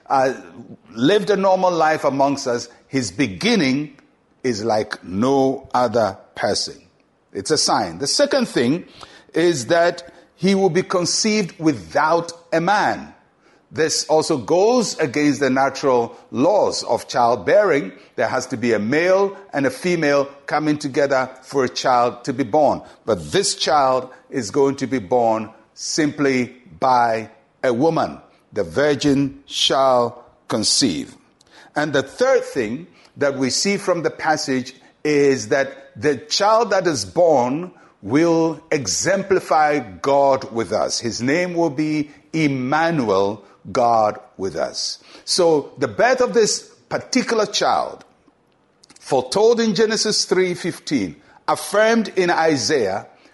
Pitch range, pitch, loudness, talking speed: 130-180 Hz, 150 Hz, -19 LUFS, 130 wpm